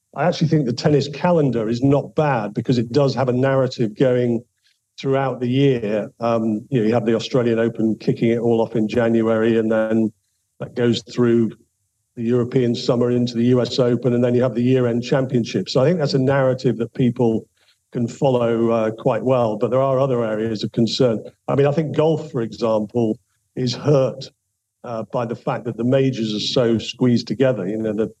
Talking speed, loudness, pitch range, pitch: 200 wpm, -19 LUFS, 115-130 Hz, 120 Hz